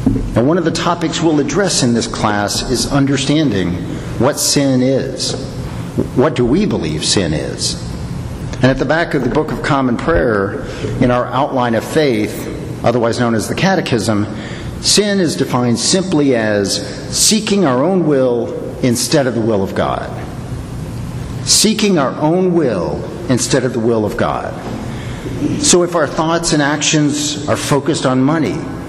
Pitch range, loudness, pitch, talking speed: 120-155 Hz, -15 LUFS, 130 Hz, 160 wpm